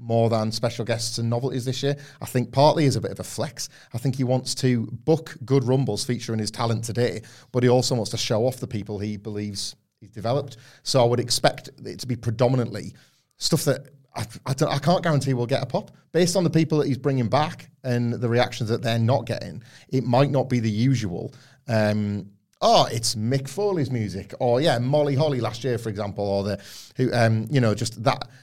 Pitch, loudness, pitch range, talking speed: 125 Hz, -24 LUFS, 115-135 Hz, 225 wpm